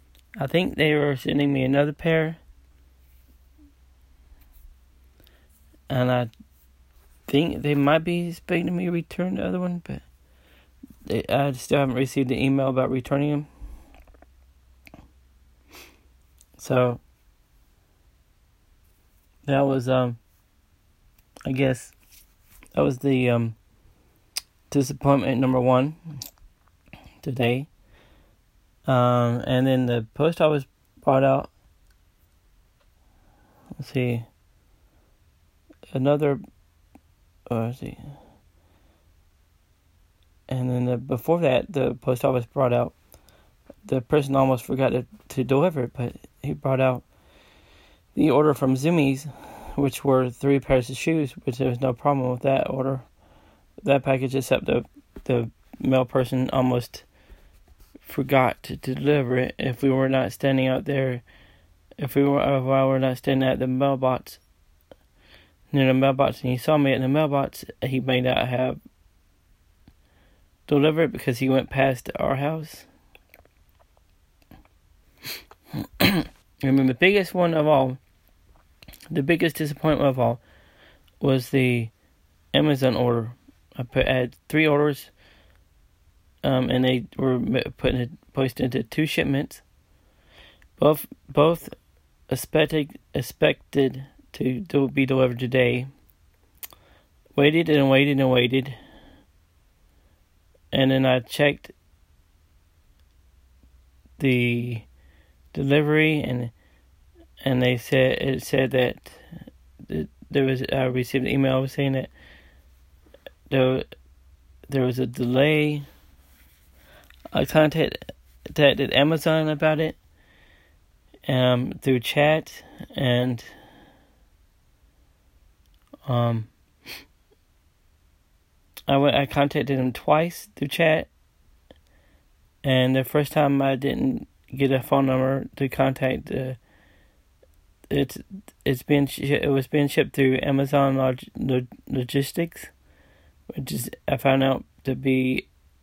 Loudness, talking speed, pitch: -23 LUFS, 115 wpm, 125 Hz